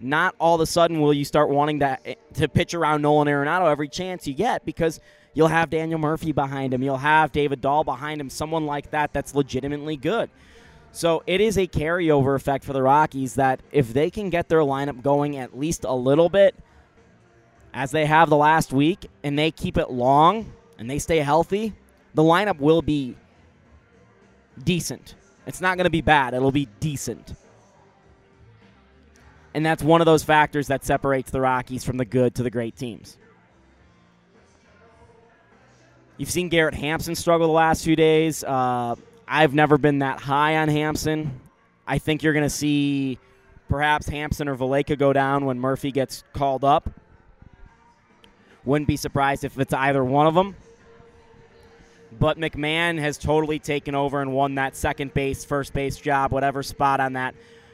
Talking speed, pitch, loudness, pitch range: 175 wpm, 145 Hz, -22 LUFS, 135-155 Hz